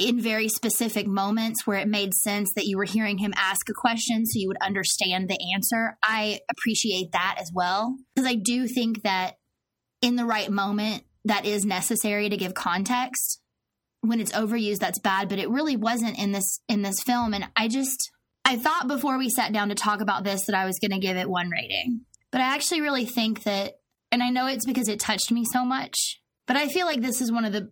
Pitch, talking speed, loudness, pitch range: 220 Hz, 225 wpm, -25 LUFS, 200-245 Hz